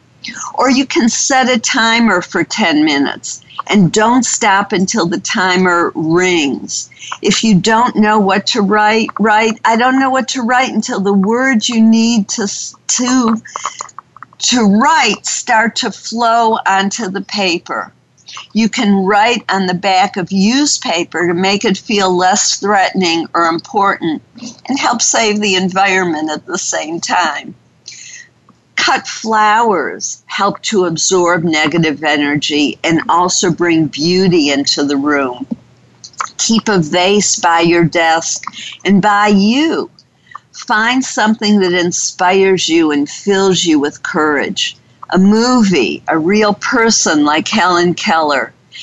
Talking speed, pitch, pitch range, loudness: 140 wpm, 200 Hz, 180-230 Hz, -12 LUFS